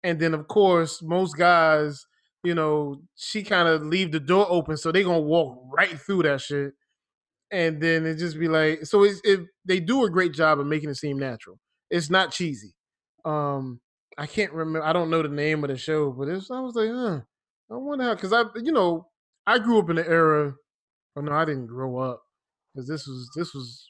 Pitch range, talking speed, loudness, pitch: 145-185 Hz, 220 wpm, -24 LUFS, 165 Hz